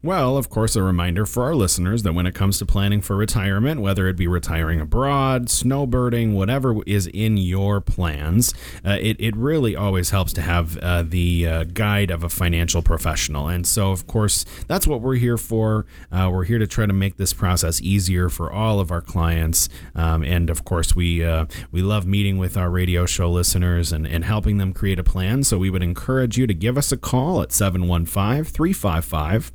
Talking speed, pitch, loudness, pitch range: 205 wpm, 95 Hz, -21 LUFS, 85-110 Hz